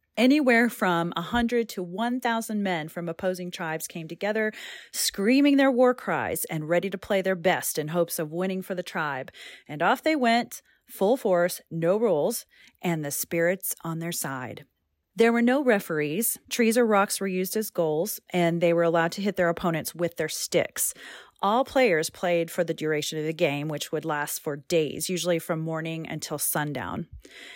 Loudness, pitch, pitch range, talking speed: -26 LUFS, 180 Hz, 160-220 Hz, 185 wpm